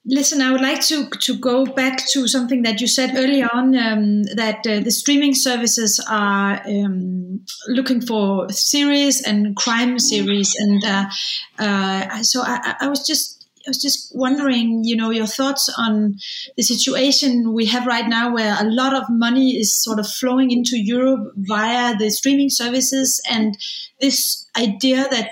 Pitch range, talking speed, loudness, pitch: 215-265 Hz, 170 wpm, -17 LUFS, 240 Hz